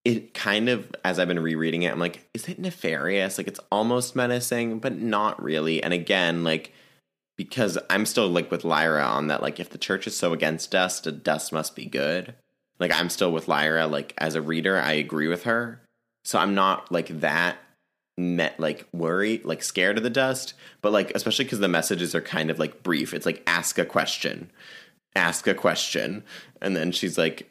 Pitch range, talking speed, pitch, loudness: 80-115 Hz, 205 wpm, 90 Hz, -25 LUFS